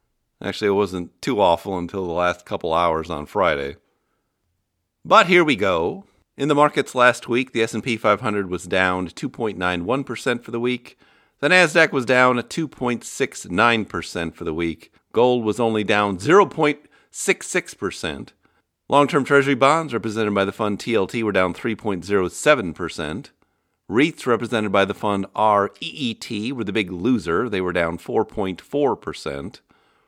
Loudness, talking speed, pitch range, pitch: -20 LUFS, 150 wpm, 90-125 Hz, 105 Hz